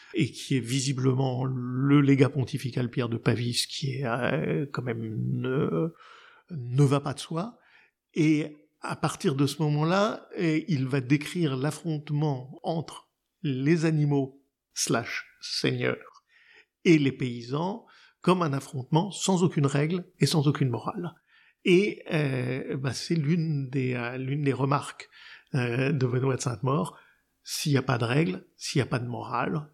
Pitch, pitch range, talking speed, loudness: 145 Hz, 130-160 Hz, 155 wpm, -27 LUFS